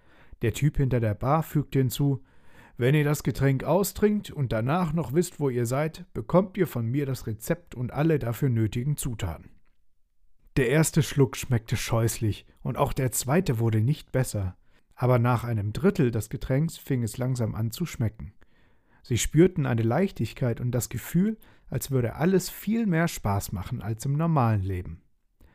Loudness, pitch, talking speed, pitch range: -27 LUFS, 130 Hz, 170 wpm, 115-155 Hz